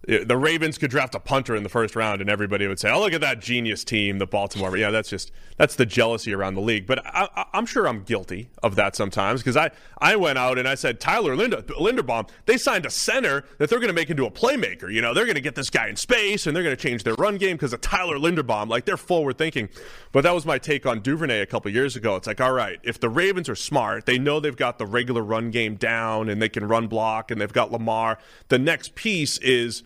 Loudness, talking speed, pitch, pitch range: -23 LUFS, 265 wpm, 120 Hz, 110-140 Hz